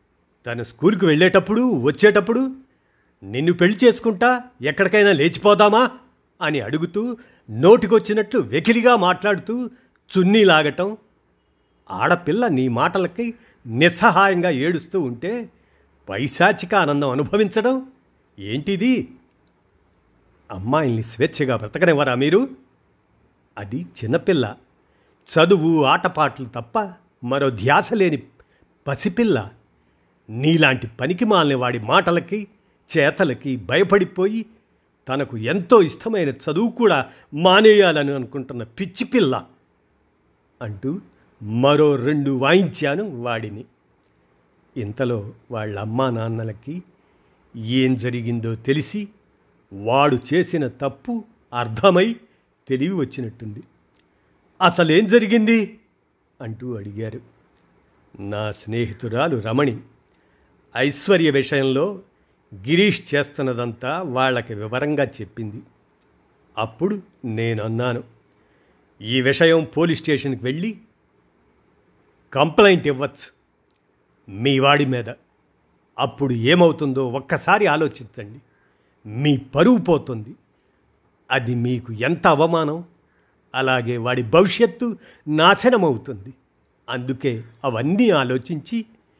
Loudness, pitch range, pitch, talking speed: -19 LUFS, 120-195 Hz, 140 Hz, 80 wpm